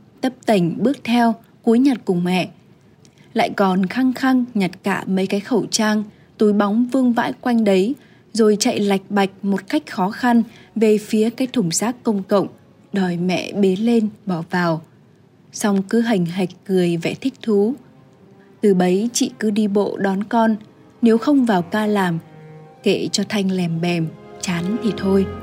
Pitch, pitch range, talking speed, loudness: 205 Hz, 185-230 Hz, 175 wpm, -19 LUFS